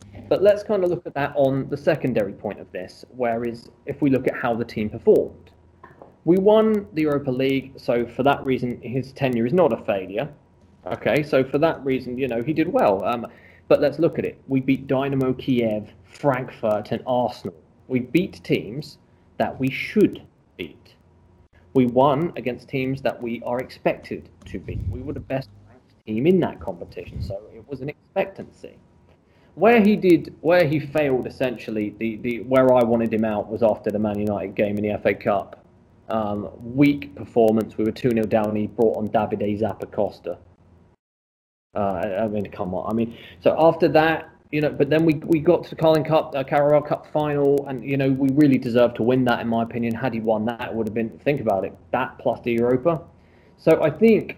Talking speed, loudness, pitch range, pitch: 205 wpm, -22 LUFS, 110-145 Hz, 125 Hz